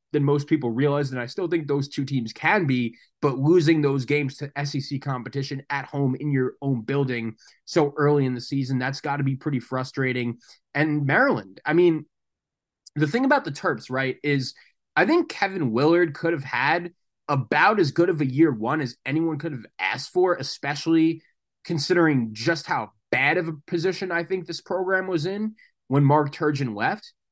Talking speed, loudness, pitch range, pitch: 190 wpm, -24 LUFS, 135-165 Hz, 145 Hz